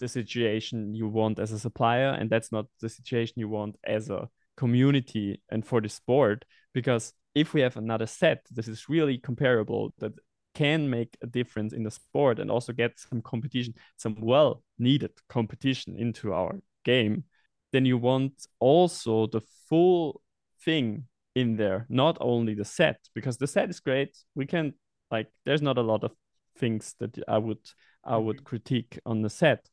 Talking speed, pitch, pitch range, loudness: 175 wpm, 120 Hz, 110-135 Hz, -28 LUFS